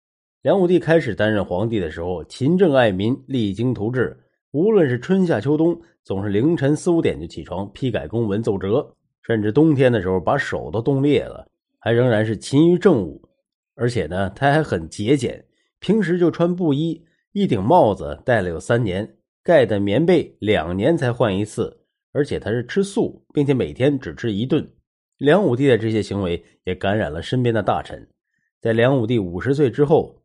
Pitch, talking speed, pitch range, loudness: 120 Hz, 270 characters per minute, 105-155 Hz, -20 LUFS